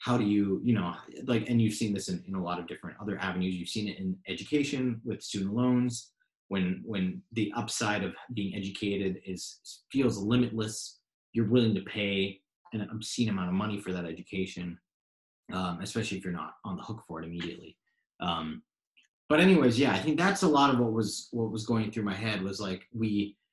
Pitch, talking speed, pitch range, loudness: 100 Hz, 205 wpm, 95-115 Hz, -31 LUFS